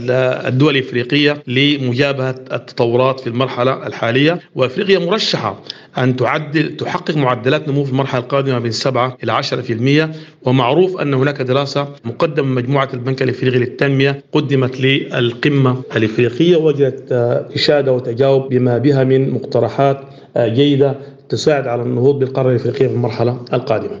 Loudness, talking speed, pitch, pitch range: -15 LUFS, 125 wpm, 130 Hz, 125-145 Hz